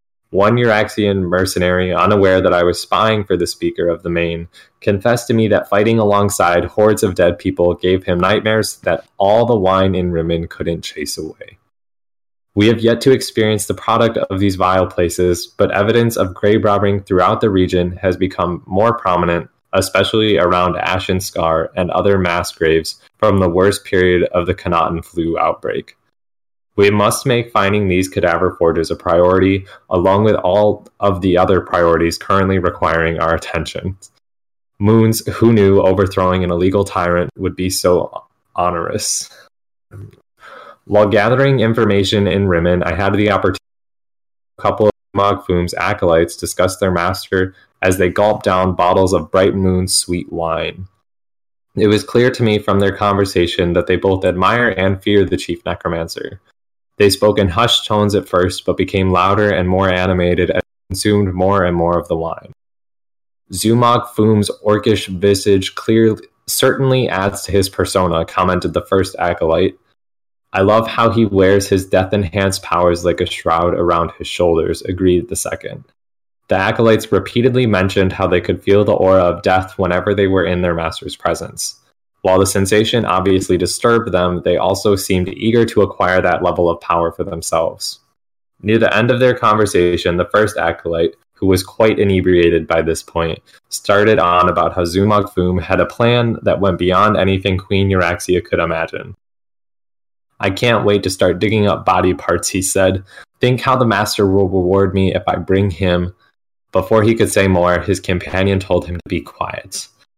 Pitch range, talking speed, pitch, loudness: 90-105 Hz, 170 wpm, 95 Hz, -15 LUFS